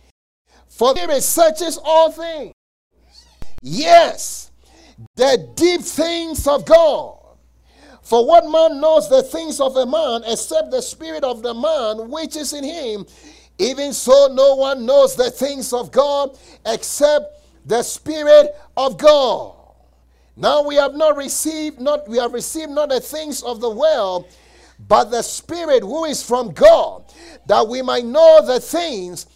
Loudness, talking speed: -16 LUFS, 145 wpm